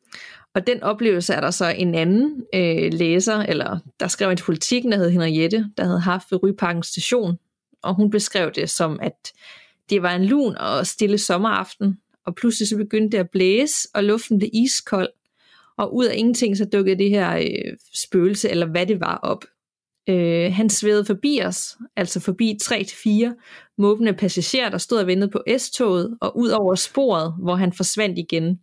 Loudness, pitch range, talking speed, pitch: -20 LUFS, 180-220 Hz, 180 wpm, 200 Hz